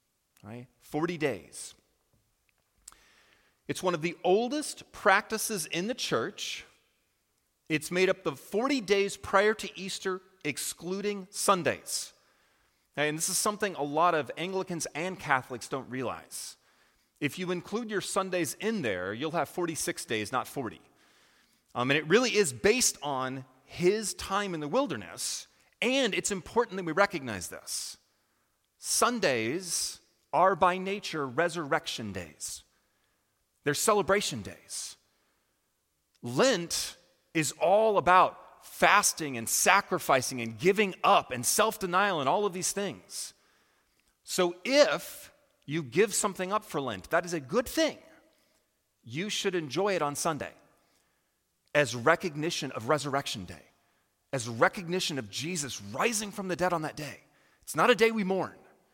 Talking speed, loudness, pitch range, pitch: 135 wpm, -29 LUFS, 140-200 Hz, 175 Hz